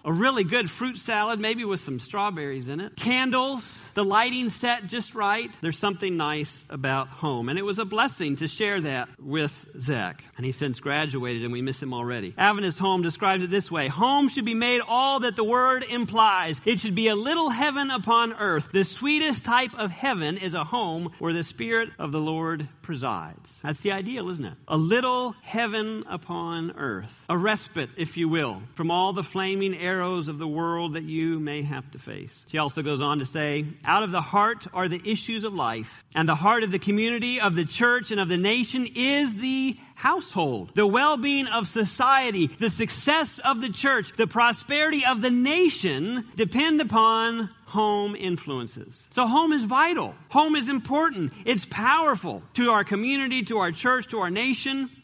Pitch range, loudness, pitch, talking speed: 160-240 Hz, -25 LUFS, 205 Hz, 190 wpm